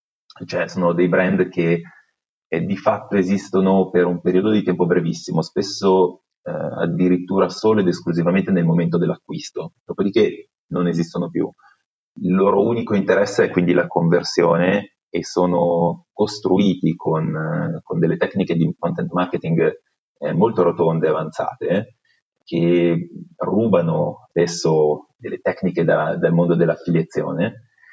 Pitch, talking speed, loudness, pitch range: 90 Hz, 130 wpm, -19 LUFS, 85-100 Hz